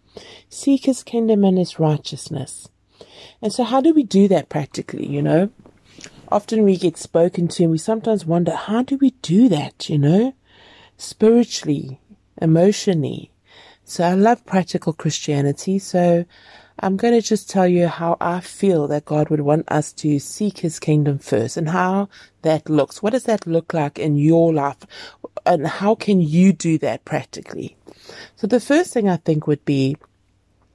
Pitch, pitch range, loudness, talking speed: 175 Hz, 150-210 Hz, -19 LUFS, 170 wpm